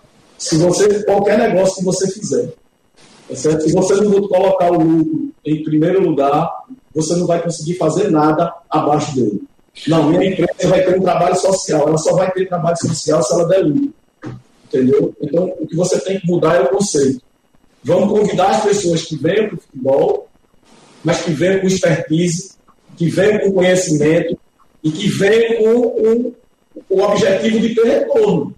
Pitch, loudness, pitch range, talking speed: 180 Hz, -15 LUFS, 165-200 Hz, 180 wpm